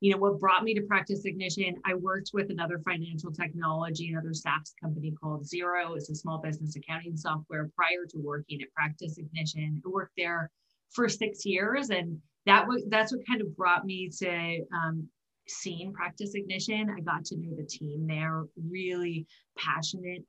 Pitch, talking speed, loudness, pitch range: 175 Hz, 175 wpm, -31 LUFS, 160-190 Hz